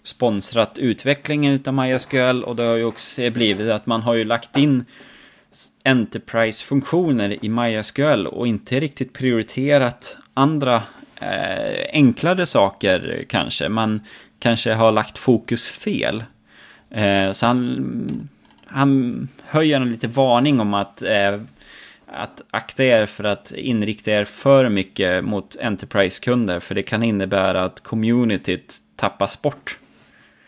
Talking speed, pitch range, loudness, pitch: 125 wpm, 110-135 Hz, -19 LUFS, 120 Hz